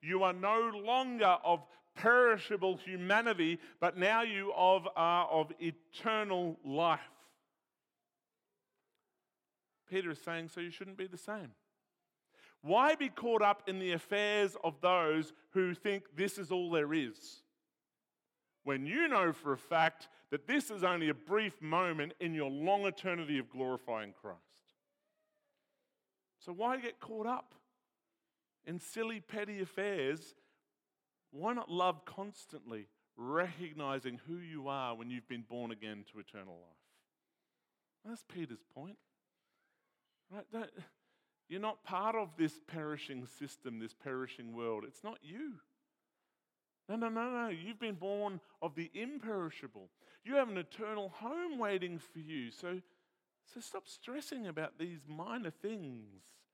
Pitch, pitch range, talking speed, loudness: 180 Hz, 160-220 Hz, 135 wpm, -36 LUFS